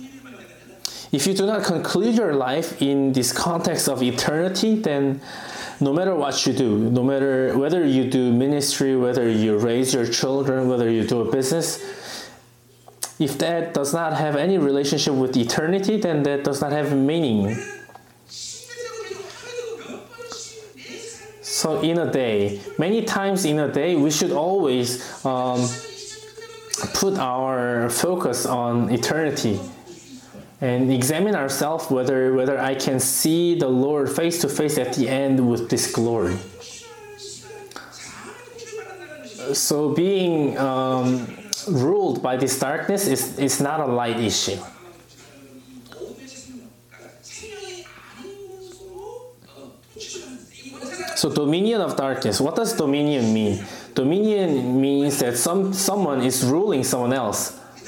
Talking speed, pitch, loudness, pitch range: 120 wpm, 145 Hz, -21 LUFS, 130-210 Hz